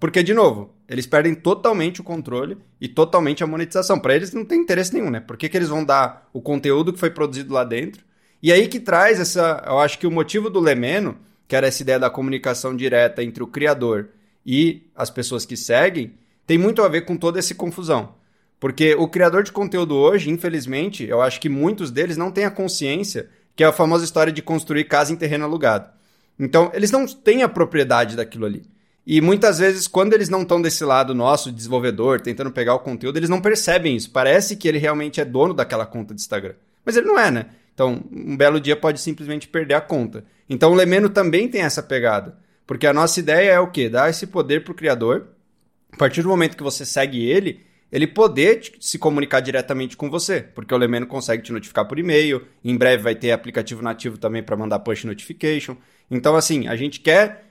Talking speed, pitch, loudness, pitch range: 210 wpm, 155 Hz, -19 LUFS, 130-175 Hz